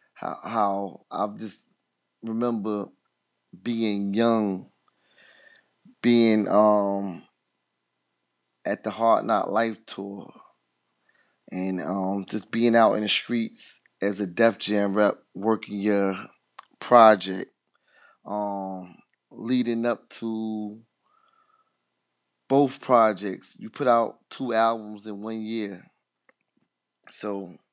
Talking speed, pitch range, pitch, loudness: 95 wpm, 100-115 Hz, 105 Hz, -25 LUFS